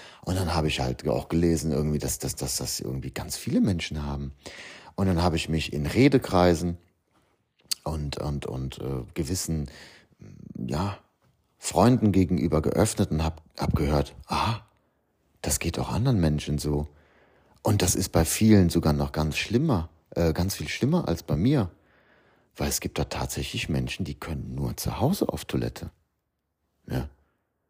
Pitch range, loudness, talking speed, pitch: 75-90 Hz, -26 LUFS, 160 wpm, 80 Hz